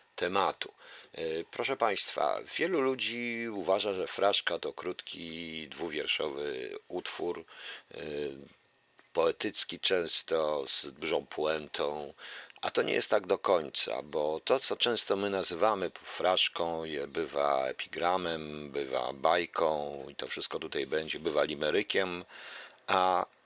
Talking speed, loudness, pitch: 110 wpm, -32 LUFS, 100 Hz